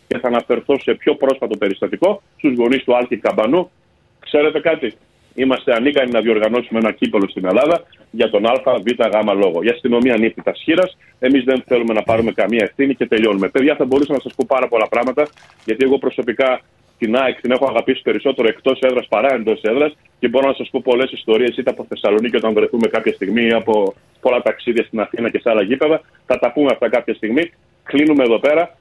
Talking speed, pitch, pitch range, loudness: 195 wpm, 130 Hz, 115-135 Hz, -16 LUFS